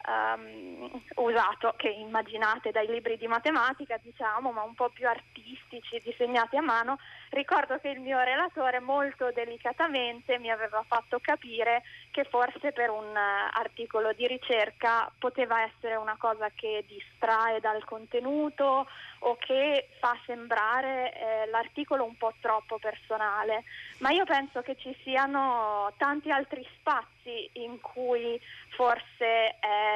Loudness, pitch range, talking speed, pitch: -30 LUFS, 225-265 Hz, 130 wpm, 240 Hz